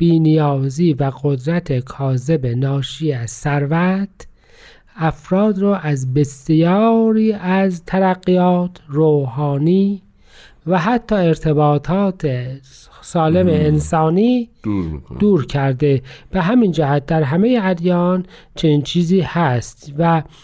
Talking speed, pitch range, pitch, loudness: 90 wpm, 145-185 Hz, 160 Hz, -17 LUFS